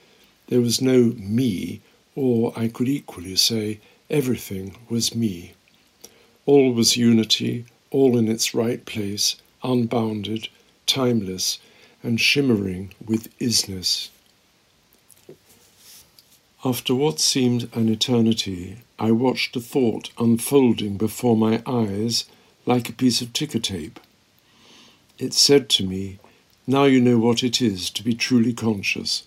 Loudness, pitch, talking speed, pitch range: -21 LUFS, 115 Hz, 120 wpm, 110-125 Hz